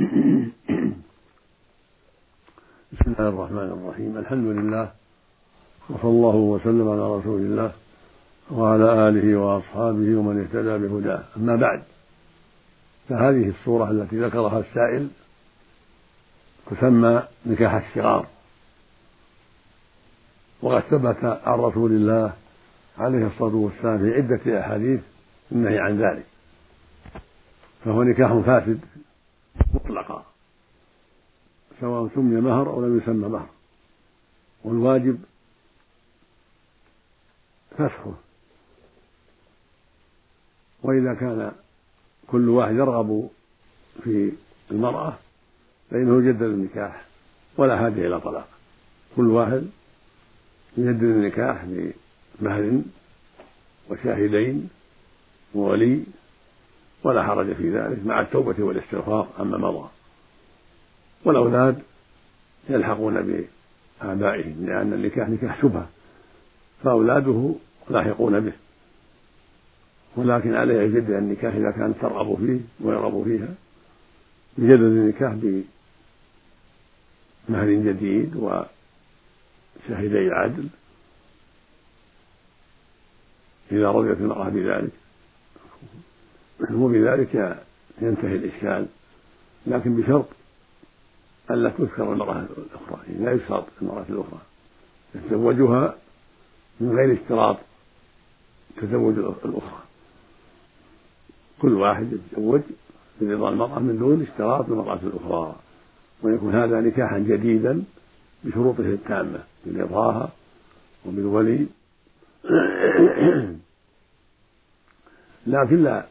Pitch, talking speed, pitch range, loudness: 110 Hz, 80 wpm, 105-120 Hz, -22 LUFS